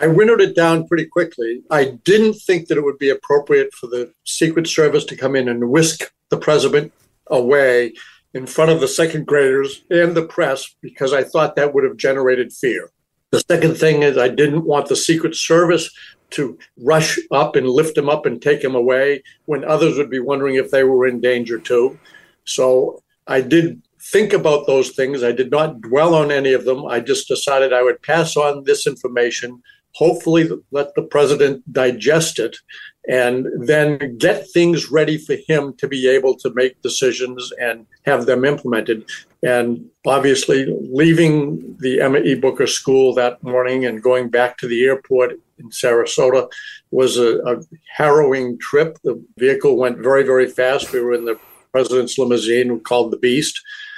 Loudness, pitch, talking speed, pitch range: -16 LUFS, 145 Hz, 180 wpm, 130-170 Hz